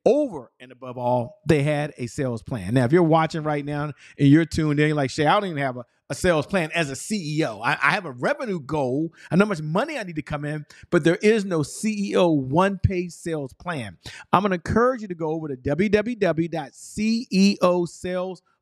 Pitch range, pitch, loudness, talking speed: 145-190 Hz, 160 Hz, -23 LUFS, 215 wpm